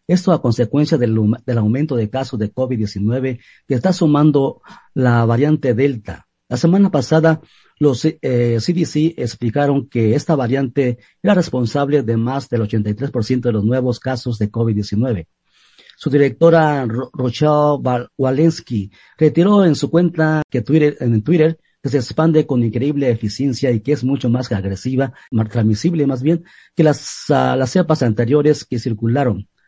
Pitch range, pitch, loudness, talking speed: 120-150 Hz, 130 Hz, -17 LUFS, 150 wpm